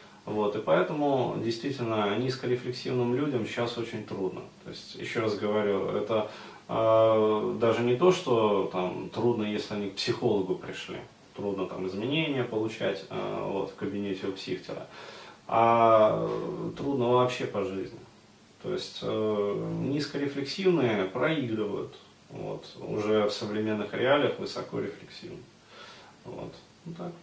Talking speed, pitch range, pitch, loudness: 125 wpm, 105-125 Hz, 110 Hz, -29 LUFS